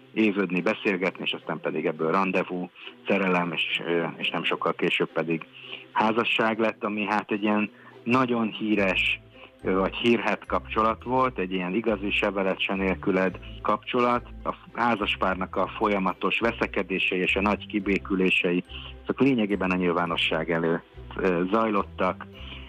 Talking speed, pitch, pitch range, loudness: 120 wpm, 100 Hz, 90-110 Hz, -25 LUFS